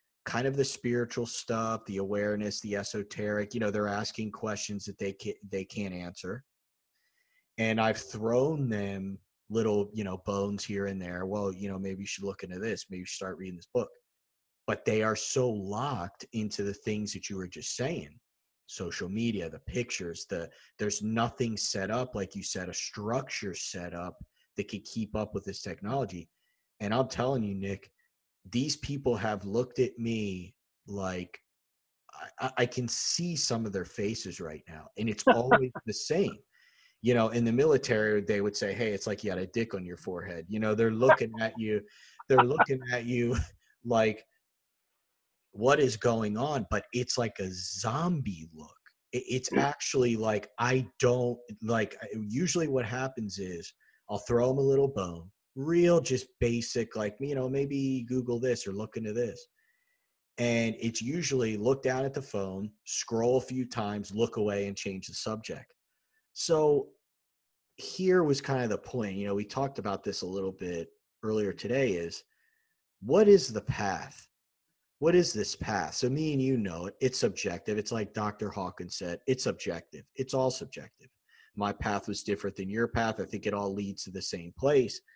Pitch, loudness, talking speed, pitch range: 110 Hz, -31 LUFS, 180 wpm, 100-125 Hz